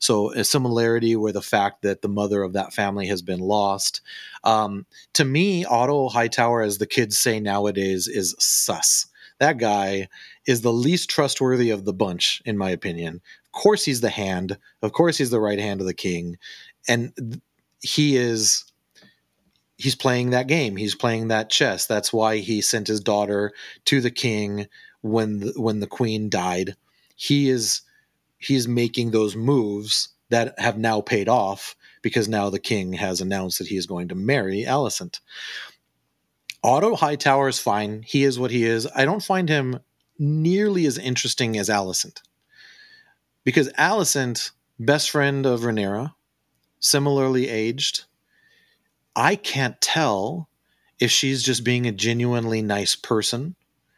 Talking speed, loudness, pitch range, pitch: 155 wpm, -22 LUFS, 105-135 Hz, 115 Hz